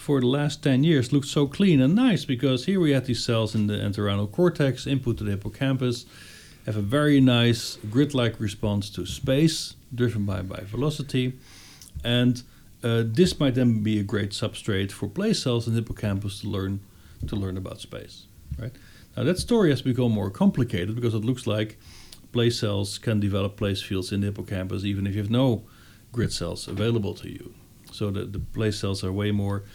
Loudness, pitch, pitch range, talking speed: -25 LUFS, 110 Hz, 100-130 Hz, 195 wpm